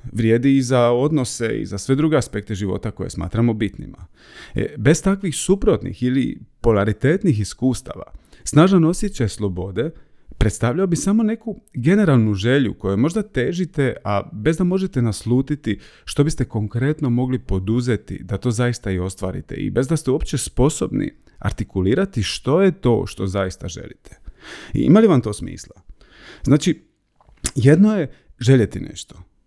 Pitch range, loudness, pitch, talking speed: 105-150 Hz, -19 LUFS, 125 Hz, 145 wpm